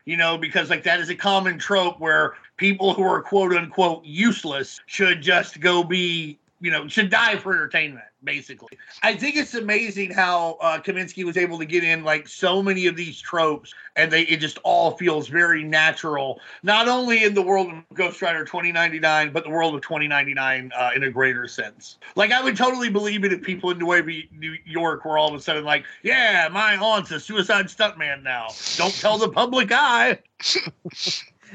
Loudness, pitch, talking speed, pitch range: -21 LUFS, 175 Hz, 190 wpm, 155-195 Hz